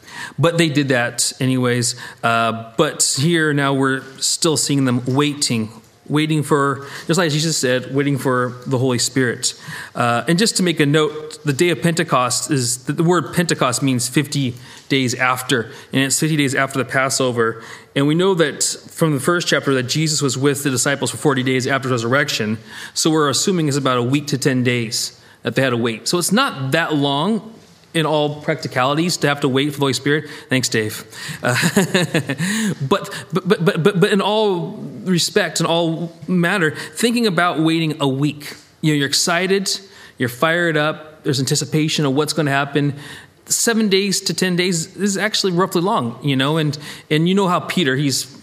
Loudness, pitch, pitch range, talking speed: -18 LUFS, 150 Hz, 130-170 Hz, 190 wpm